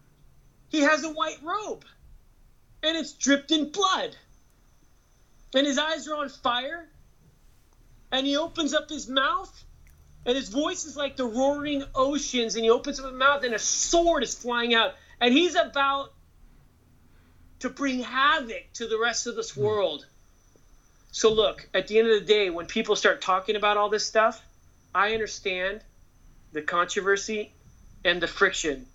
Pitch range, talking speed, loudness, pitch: 215-290 Hz, 160 wpm, -25 LUFS, 255 Hz